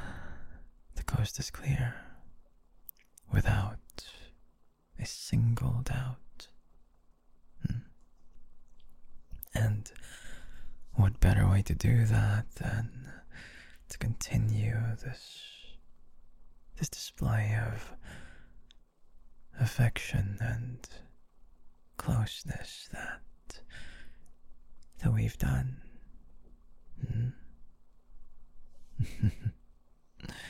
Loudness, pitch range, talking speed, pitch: -33 LUFS, 80-110 Hz, 60 wpm, 80 Hz